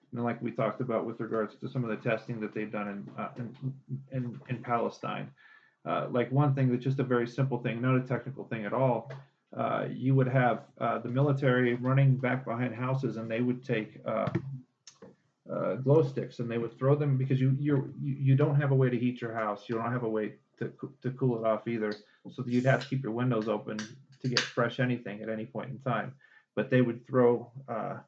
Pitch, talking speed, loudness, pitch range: 125 Hz, 230 wpm, -31 LUFS, 115-135 Hz